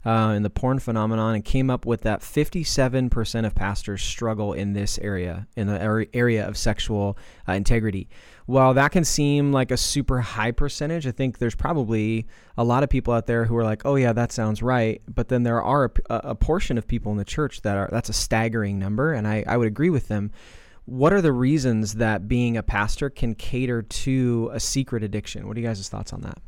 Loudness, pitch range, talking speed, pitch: -23 LUFS, 105-130 Hz, 220 wpm, 115 Hz